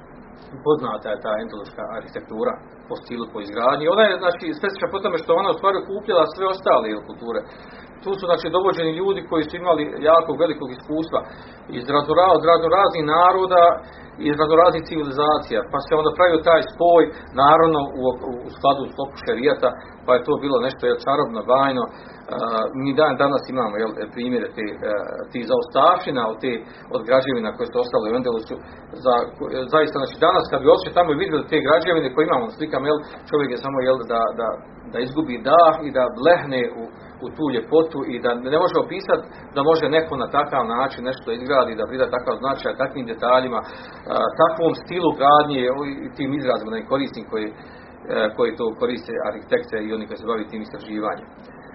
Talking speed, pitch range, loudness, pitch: 175 wpm, 130-170 Hz, -20 LUFS, 155 Hz